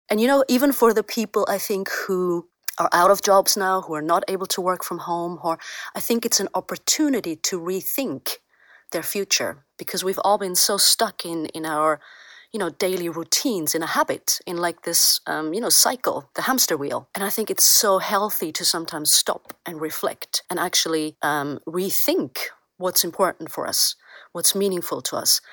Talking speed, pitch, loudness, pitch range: 195 wpm, 190 Hz, -21 LUFS, 170-205 Hz